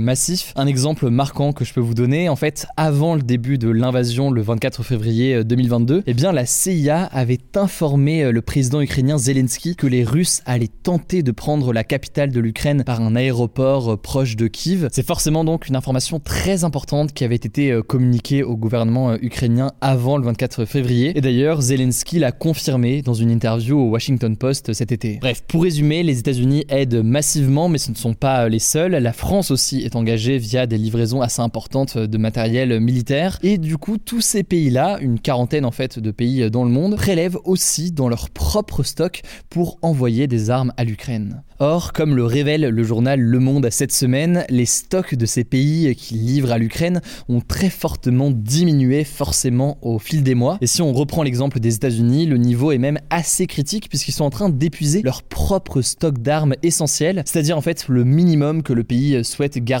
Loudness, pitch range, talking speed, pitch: -18 LUFS, 120-155 Hz, 195 wpm, 135 Hz